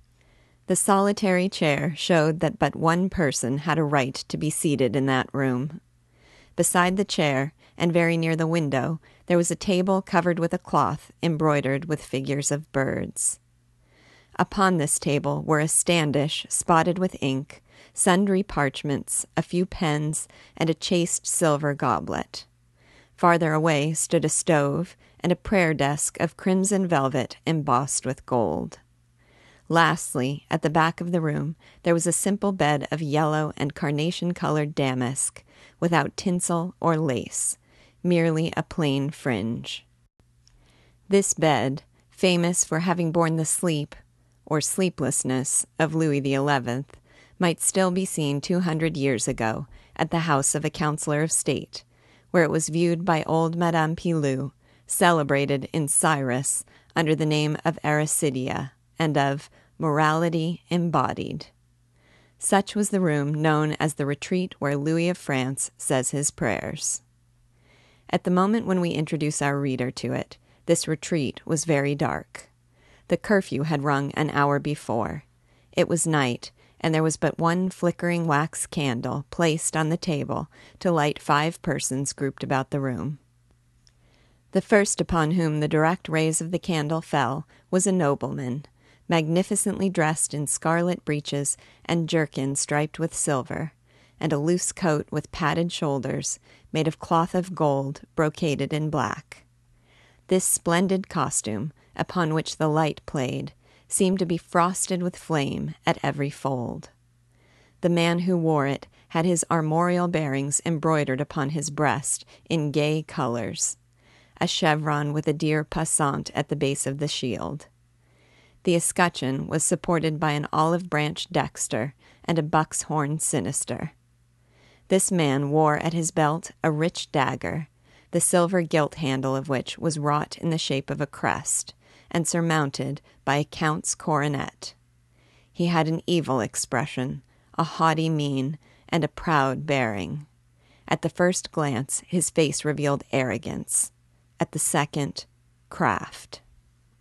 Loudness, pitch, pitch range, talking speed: -24 LUFS, 150 Hz, 135-170 Hz, 145 wpm